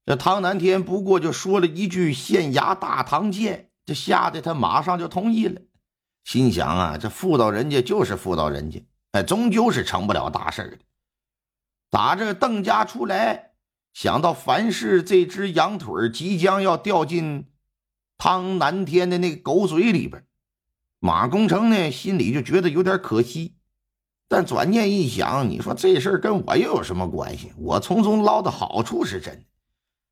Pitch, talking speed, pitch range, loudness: 180 Hz, 235 characters per minute, 150-195 Hz, -21 LUFS